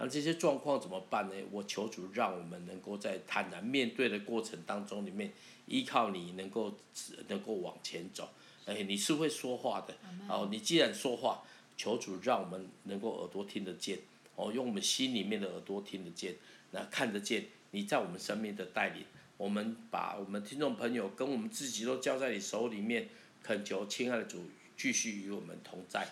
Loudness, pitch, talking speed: -37 LUFS, 120 Hz, 285 characters per minute